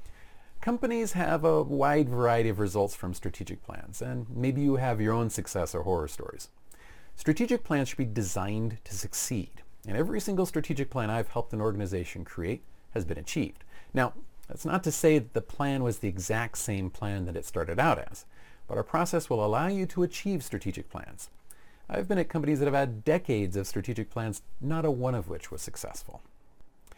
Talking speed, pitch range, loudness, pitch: 190 wpm, 100-155 Hz, -30 LUFS, 120 Hz